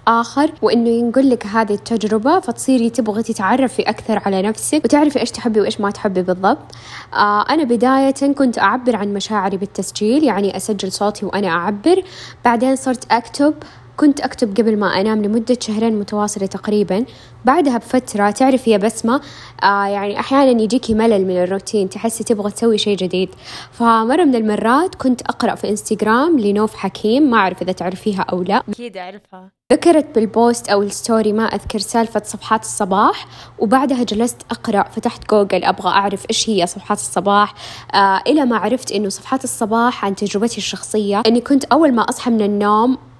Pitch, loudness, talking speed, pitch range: 220 Hz, -16 LUFS, 160 wpm, 205-245 Hz